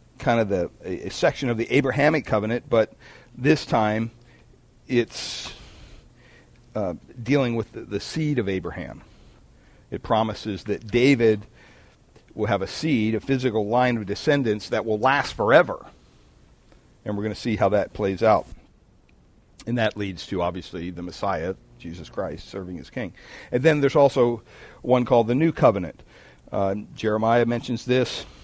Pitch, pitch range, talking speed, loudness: 115 Hz, 100-125 Hz, 150 wpm, -23 LUFS